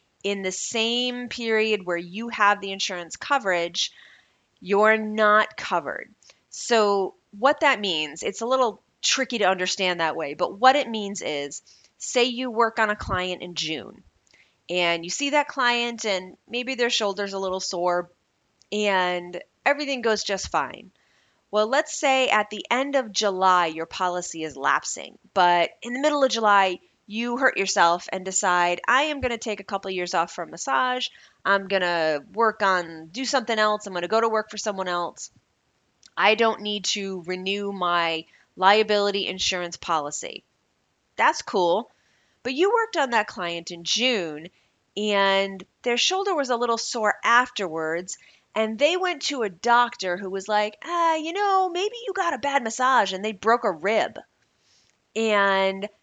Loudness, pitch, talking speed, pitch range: -23 LUFS, 210 Hz, 170 wpm, 185-240 Hz